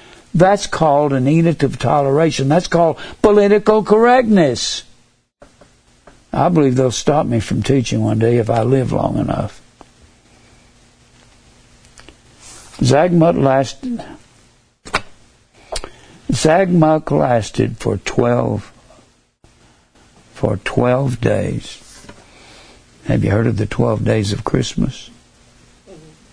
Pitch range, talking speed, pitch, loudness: 115-170 Hz, 95 wpm, 135 Hz, -15 LUFS